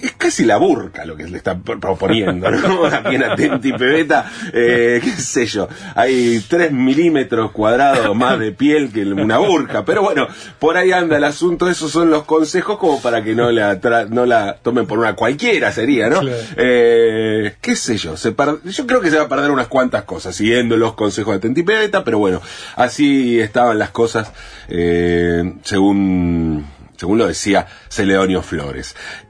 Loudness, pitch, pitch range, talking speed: -15 LUFS, 120 Hz, 105-155 Hz, 180 wpm